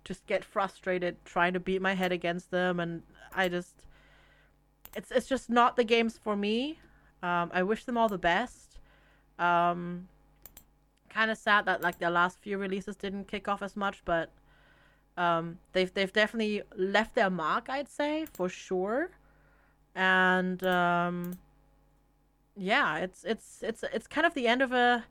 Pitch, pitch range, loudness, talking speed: 185 Hz, 175-215 Hz, -30 LUFS, 165 wpm